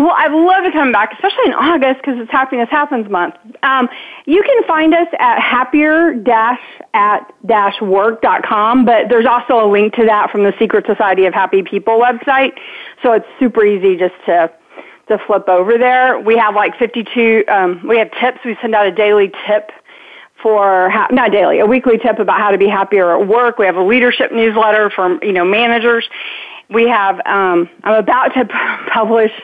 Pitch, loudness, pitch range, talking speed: 225 Hz, -12 LUFS, 205-260 Hz, 195 wpm